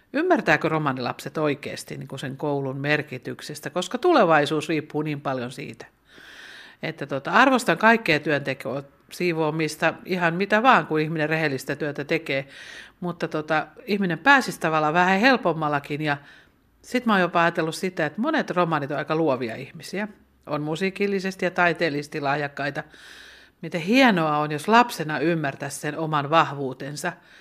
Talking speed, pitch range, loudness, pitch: 135 wpm, 145-180 Hz, -23 LUFS, 160 Hz